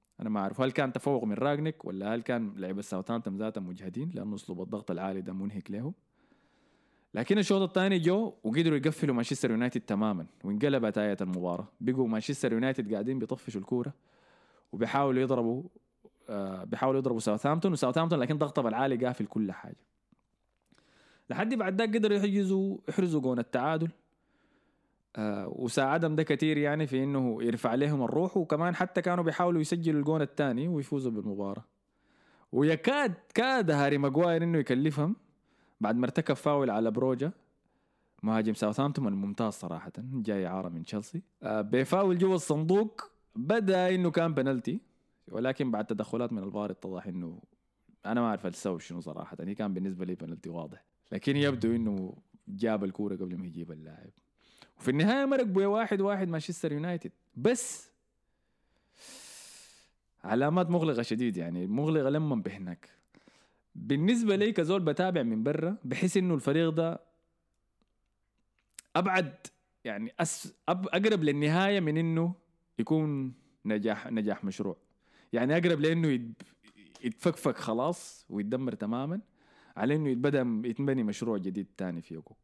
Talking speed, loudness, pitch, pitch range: 140 wpm, -31 LUFS, 140 Hz, 110-170 Hz